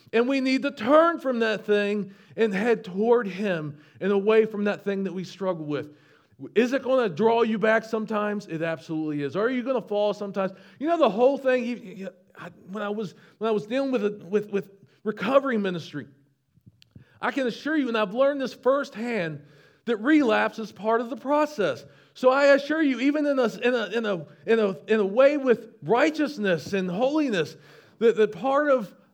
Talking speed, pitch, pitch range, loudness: 200 wpm, 220 Hz, 195-255 Hz, -25 LUFS